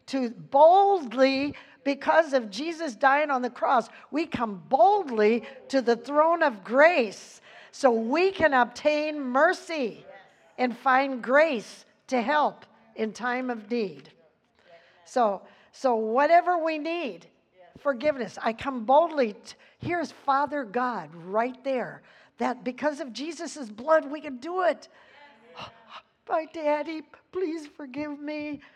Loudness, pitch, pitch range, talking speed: -25 LUFS, 275 Hz, 240-310 Hz, 125 wpm